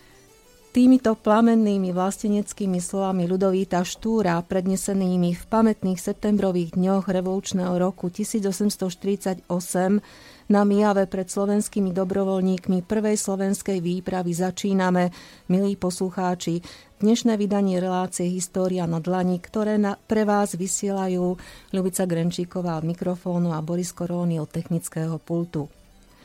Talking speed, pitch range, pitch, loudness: 105 wpm, 180-200 Hz, 190 Hz, -23 LUFS